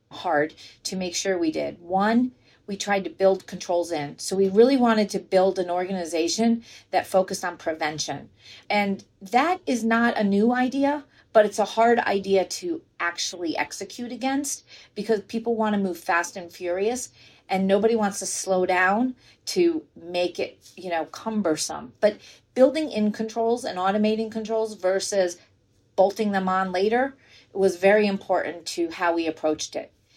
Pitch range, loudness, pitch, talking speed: 175-225 Hz, -24 LUFS, 195 Hz, 165 wpm